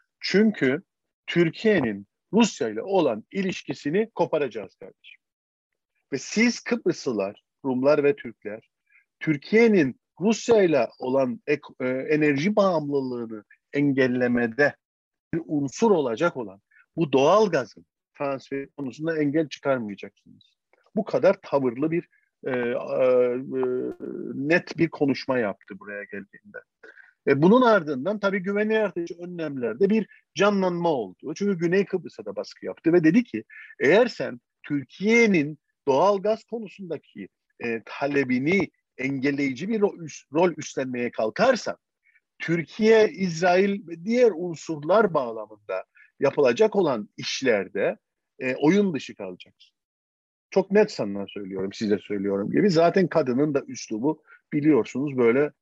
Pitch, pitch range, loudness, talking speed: 155 Hz, 130-205 Hz, -24 LUFS, 110 wpm